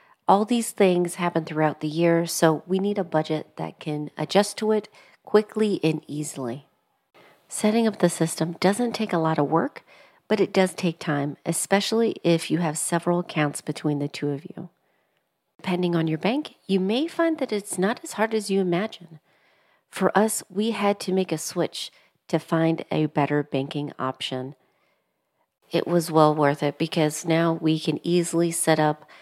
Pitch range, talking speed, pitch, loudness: 155-195 Hz, 180 wpm, 170 Hz, -24 LUFS